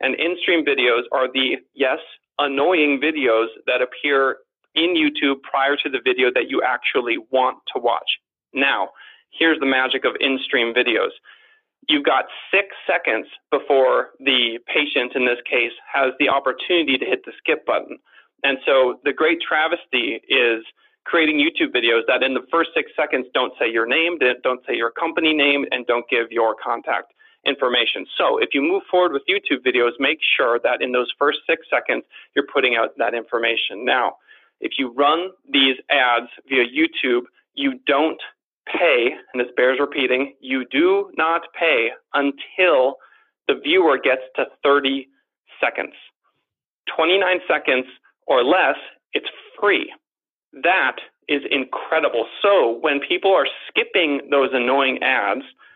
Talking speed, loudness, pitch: 155 wpm, -19 LUFS, 145 Hz